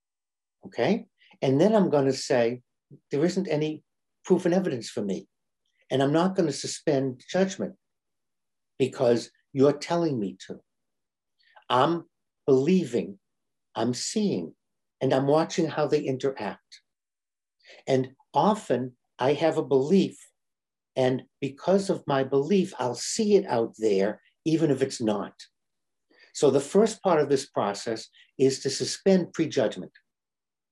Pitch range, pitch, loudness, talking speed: 130-175 Hz, 140 Hz, -26 LUFS, 135 wpm